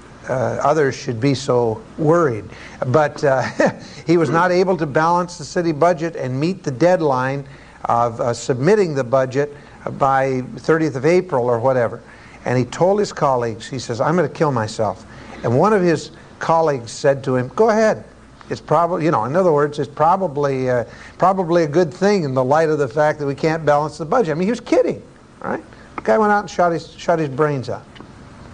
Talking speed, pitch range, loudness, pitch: 205 wpm, 130-170 Hz, -18 LUFS, 150 Hz